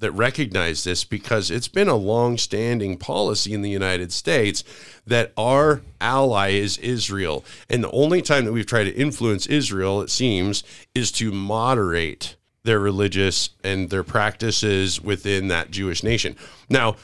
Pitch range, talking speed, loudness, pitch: 95-120 Hz, 155 wpm, -21 LUFS, 105 Hz